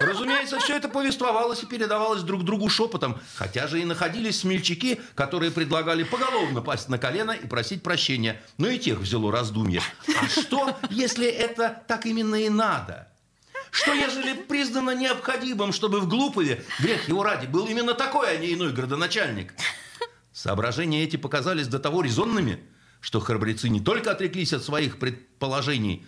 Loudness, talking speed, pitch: -25 LUFS, 155 wpm, 185 Hz